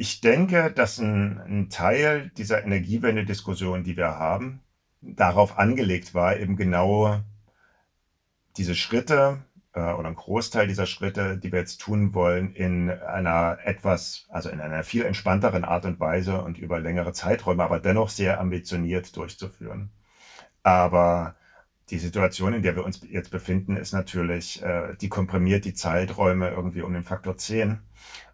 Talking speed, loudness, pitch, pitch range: 150 wpm, -25 LUFS, 95 Hz, 90-100 Hz